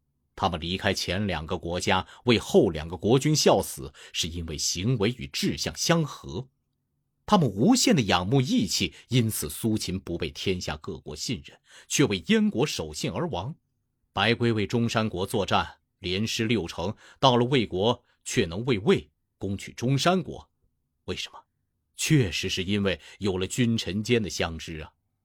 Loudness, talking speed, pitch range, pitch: -26 LUFS, 235 characters per minute, 90-125 Hz, 105 Hz